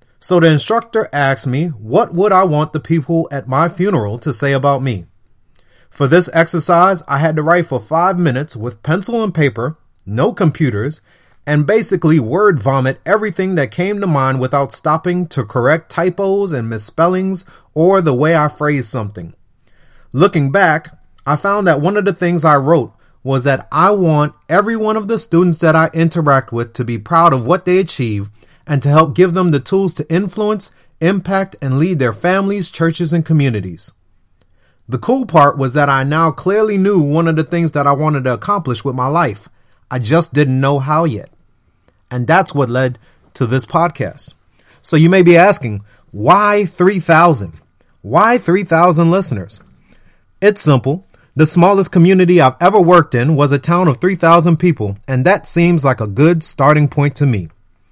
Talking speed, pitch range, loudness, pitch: 180 wpm, 130-180 Hz, -13 LUFS, 155 Hz